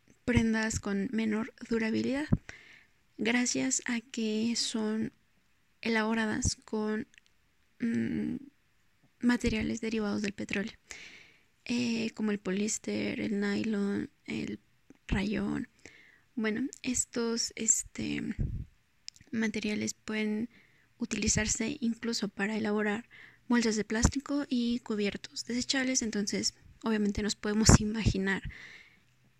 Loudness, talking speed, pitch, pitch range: -31 LUFS, 90 wpm, 225 Hz, 210-240 Hz